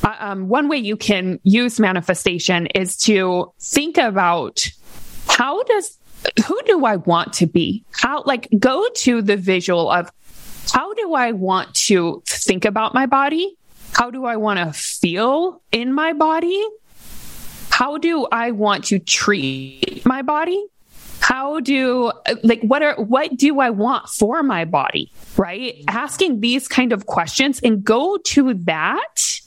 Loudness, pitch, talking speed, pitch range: -18 LUFS, 235 Hz, 155 wpm, 200-290 Hz